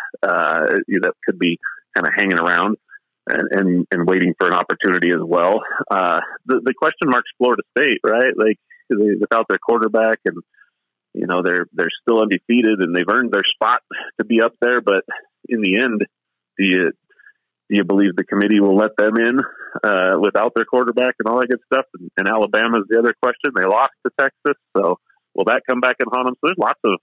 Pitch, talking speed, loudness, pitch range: 110 Hz, 210 wpm, -17 LUFS, 100-120 Hz